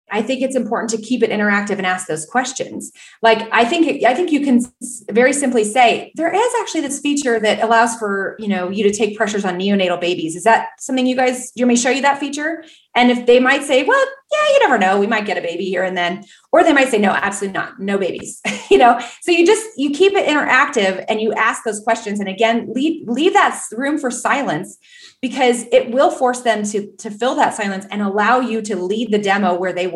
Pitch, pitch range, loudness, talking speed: 235 Hz, 205-270 Hz, -16 LUFS, 235 wpm